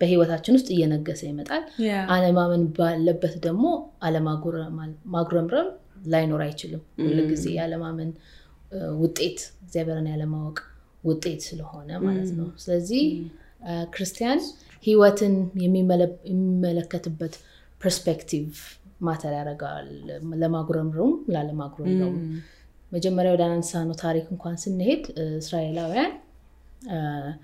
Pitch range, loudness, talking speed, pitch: 160-185 Hz, -25 LUFS, 85 wpm, 170 Hz